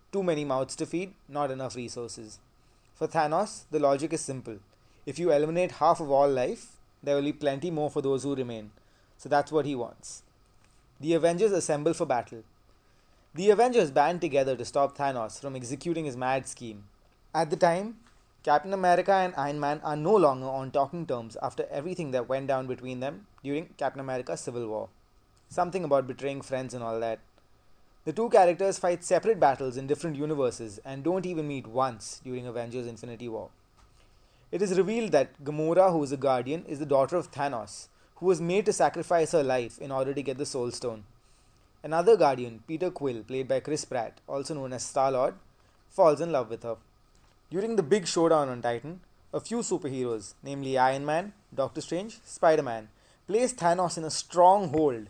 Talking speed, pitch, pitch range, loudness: 180 wpm, 140 Hz, 120-165 Hz, -28 LUFS